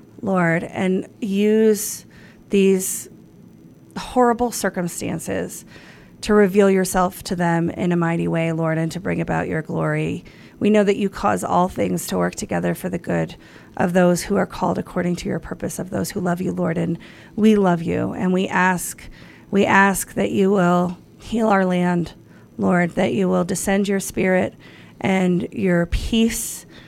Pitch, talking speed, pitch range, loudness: 185 Hz, 165 wpm, 170-200 Hz, -20 LUFS